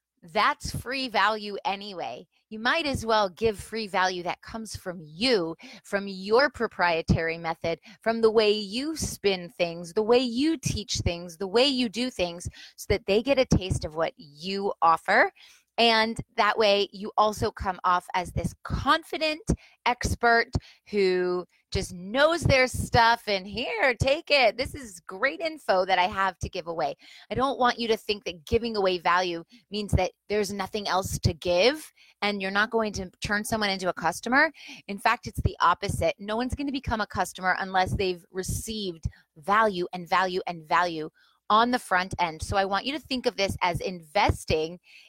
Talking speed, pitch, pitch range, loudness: 180 wpm, 205 Hz, 180-235 Hz, -26 LUFS